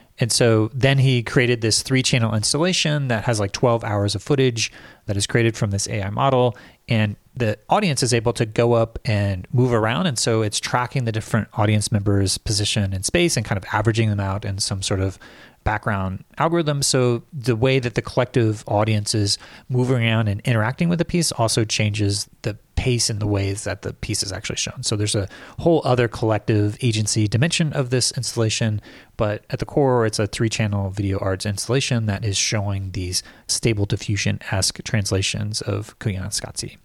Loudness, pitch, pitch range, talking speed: -21 LUFS, 110 Hz, 105-125 Hz, 190 wpm